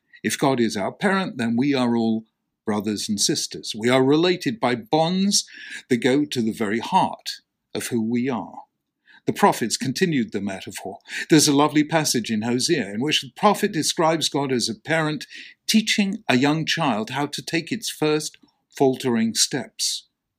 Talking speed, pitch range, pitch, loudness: 170 wpm, 120-165 Hz, 145 Hz, -22 LUFS